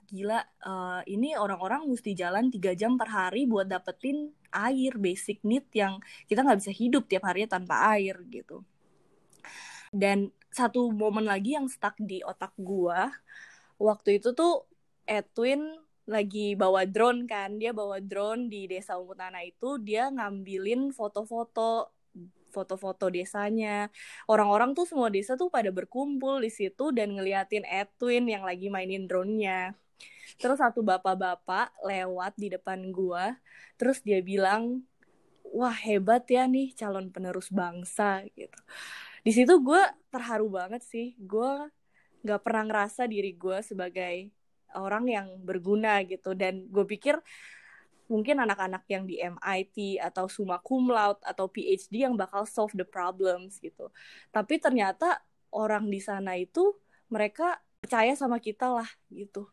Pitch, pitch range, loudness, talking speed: 210 Hz, 190-240 Hz, -29 LUFS, 140 wpm